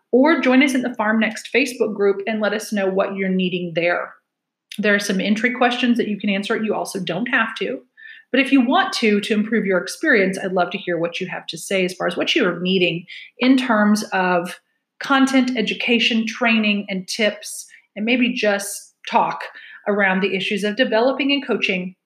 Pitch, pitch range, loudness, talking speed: 210 Hz, 195-245 Hz, -19 LUFS, 200 wpm